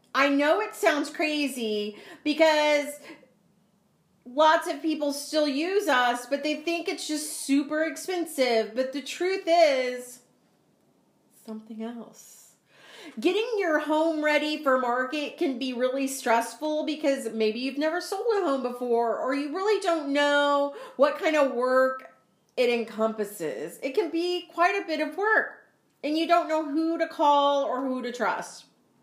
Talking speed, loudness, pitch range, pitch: 150 wpm, -26 LUFS, 255-325 Hz, 290 Hz